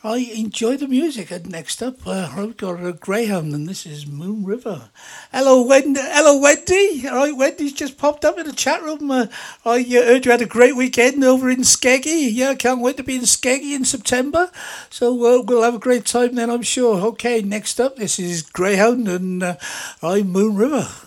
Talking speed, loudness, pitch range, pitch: 210 wpm, -17 LUFS, 205-270 Hz, 245 Hz